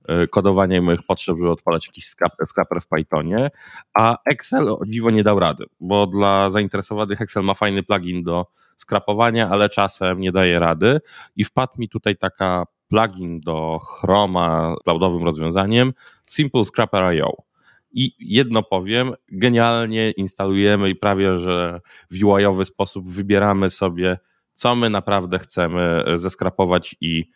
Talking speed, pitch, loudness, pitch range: 140 wpm, 95 Hz, -19 LUFS, 90-105 Hz